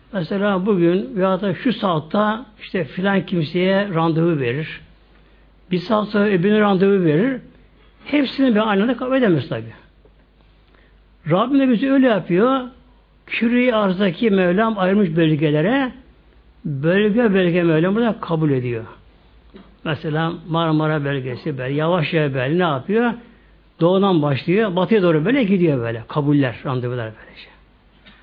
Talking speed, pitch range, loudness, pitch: 125 wpm, 155-215 Hz, -18 LUFS, 180 Hz